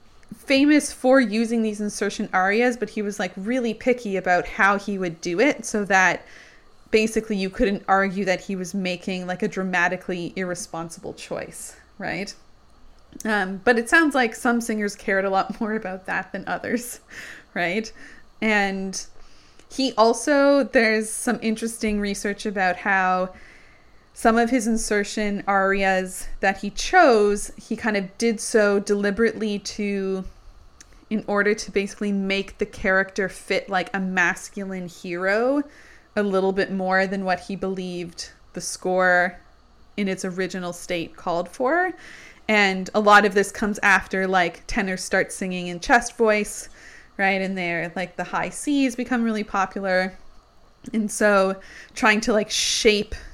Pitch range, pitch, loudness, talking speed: 190-225 Hz, 205 Hz, -22 LUFS, 150 wpm